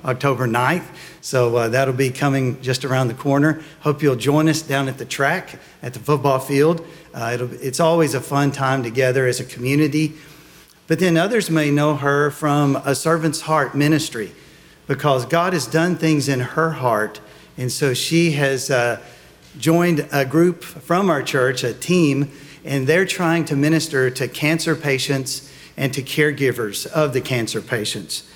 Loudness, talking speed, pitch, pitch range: -19 LUFS, 170 wpm, 140 Hz, 130-160 Hz